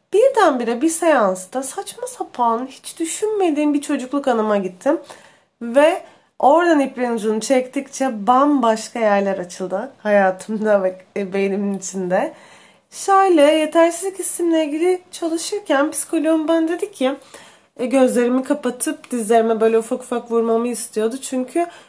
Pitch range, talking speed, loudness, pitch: 225-325 Hz, 110 wpm, -19 LUFS, 265 Hz